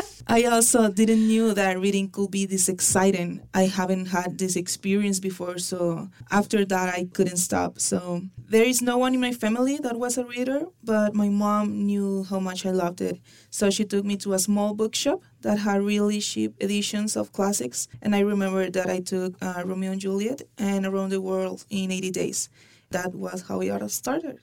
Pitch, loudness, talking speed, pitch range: 195 Hz, -25 LUFS, 200 wpm, 185-210 Hz